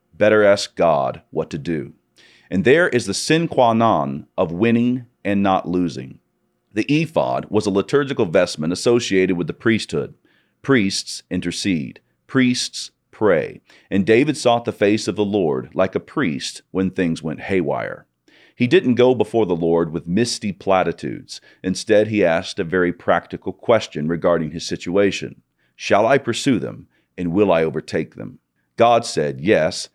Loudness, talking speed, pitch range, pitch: -19 LUFS, 155 wpm, 90-115 Hz, 100 Hz